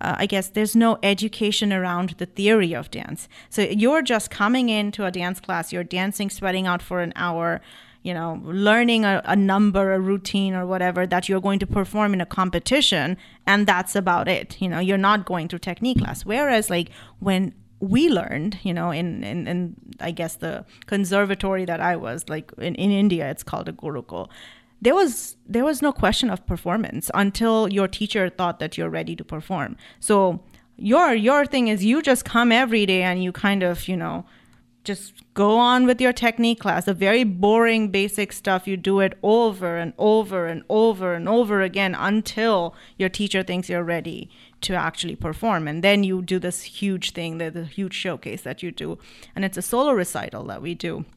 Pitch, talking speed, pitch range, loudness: 195 Hz, 195 wpm, 175-215 Hz, -22 LUFS